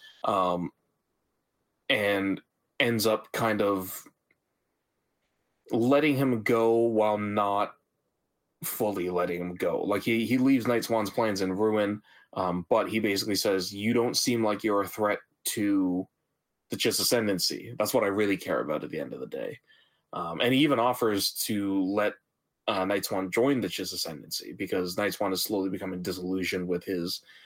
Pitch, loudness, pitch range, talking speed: 100 Hz, -28 LUFS, 95-115 Hz, 160 wpm